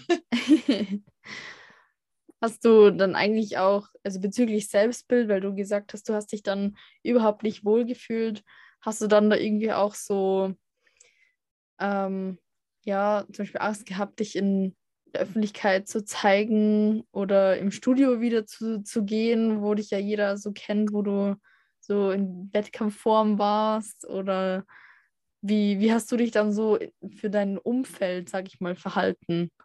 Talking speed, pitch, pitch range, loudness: 145 wpm, 210 Hz, 195-220 Hz, -25 LUFS